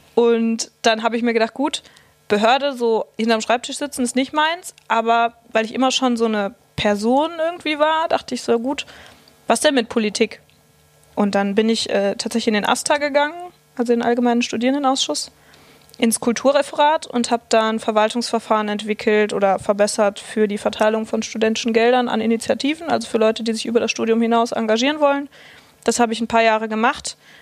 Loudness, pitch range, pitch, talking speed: -19 LUFS, 220-265 Hz, 230 Hz, 185 wpm